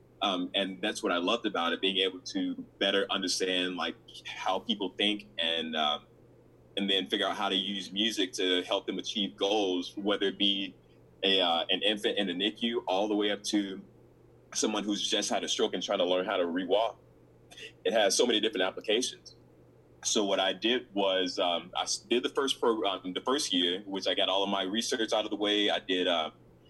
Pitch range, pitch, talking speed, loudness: 90-105 Hz, 100 Hz, 215 wpm, -29 LUFS